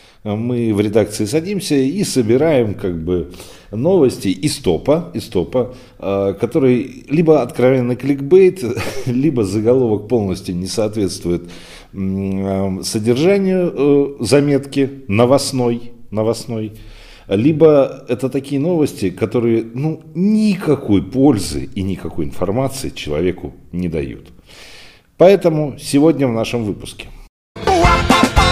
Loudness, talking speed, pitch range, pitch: -16 LUFS, 100 wpm, 100-140 Hz, 120 Hz